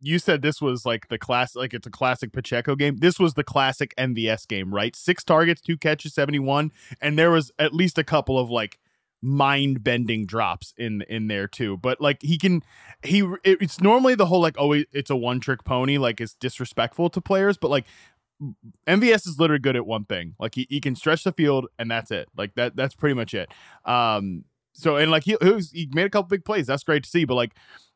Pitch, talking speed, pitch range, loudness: 140 Hz, 230 wpm, 120-165 Hz, -23 LUFS